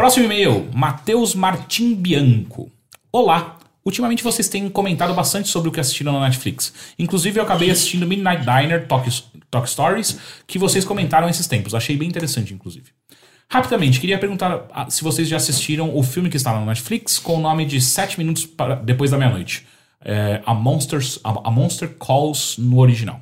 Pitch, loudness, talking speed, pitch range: 155 Hz, -18 LUFS, 175 wpm, 130-185 Hz